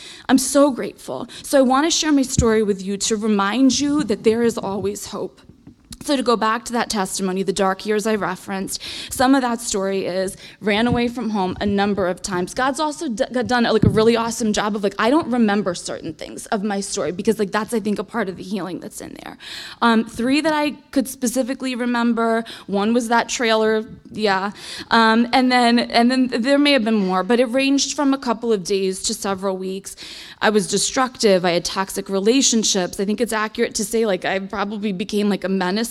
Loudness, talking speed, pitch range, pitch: -19 LUFS, 220 wpm, 200-245 Hz, 220 Hz